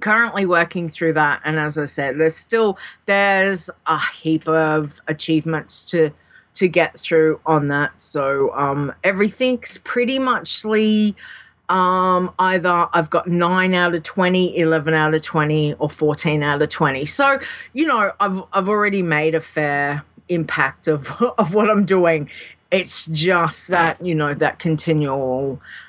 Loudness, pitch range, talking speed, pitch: -18 LUFS, 155-190 Hz, 155 wpm, 170 Hz